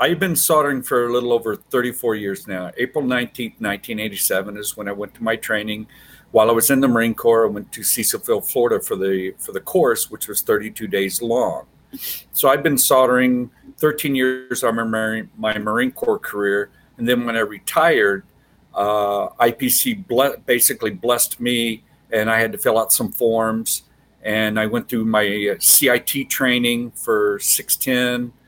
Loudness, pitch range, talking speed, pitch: -19 LUFS, 105-125 Hz, 175 wpm, 115 Hz